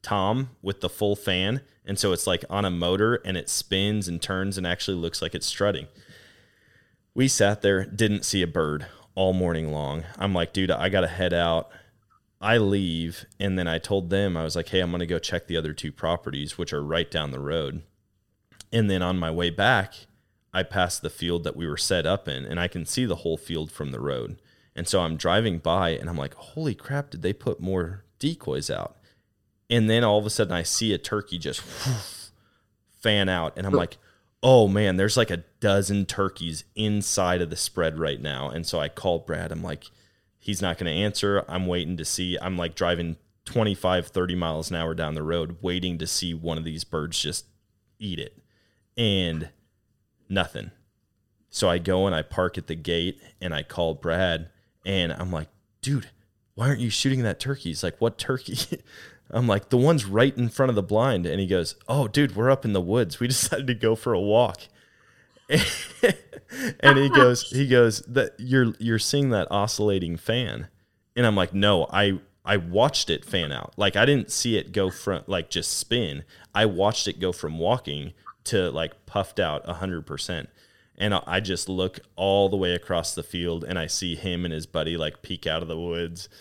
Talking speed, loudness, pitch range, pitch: 205 wpm, -25 LUFS, 85-105 Hz, 95 Hz